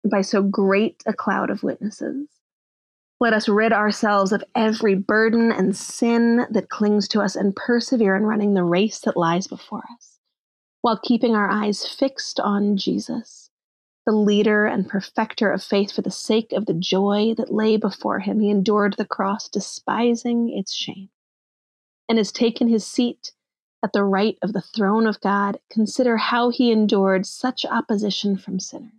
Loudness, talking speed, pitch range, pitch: -21 LUFS, 170 wpm, 200-230 Hz, 210 Hz